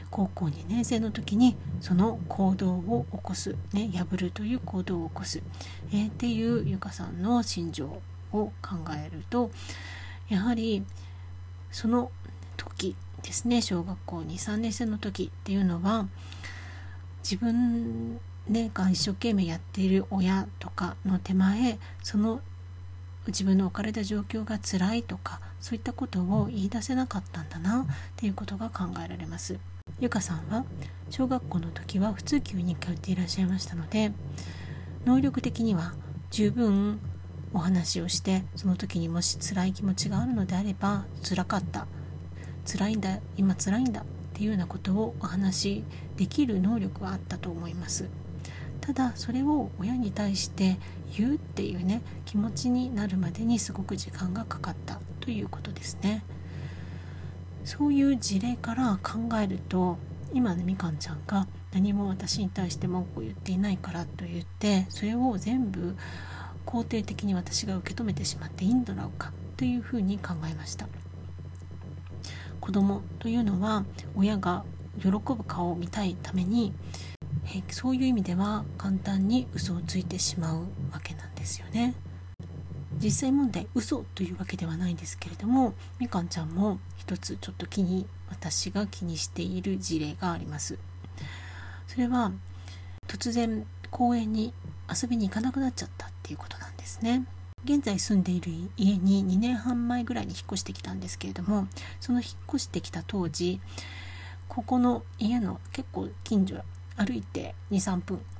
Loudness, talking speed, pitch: -30 LUFS, 305 characters per minute, 95 Hz